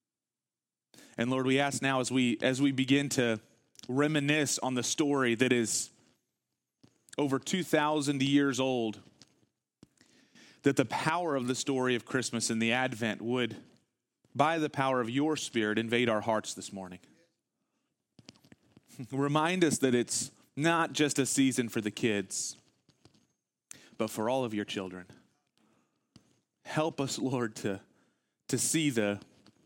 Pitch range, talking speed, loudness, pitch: 115-140 Hz, 140 wpm, -30 LUFS, 130 Hz